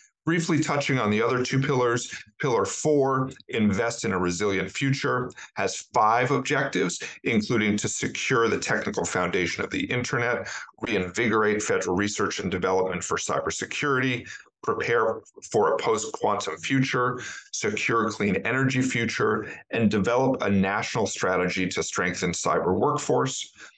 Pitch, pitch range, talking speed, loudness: 120 Hz, 100-135 Hz, 135 wpm, -25 LUFS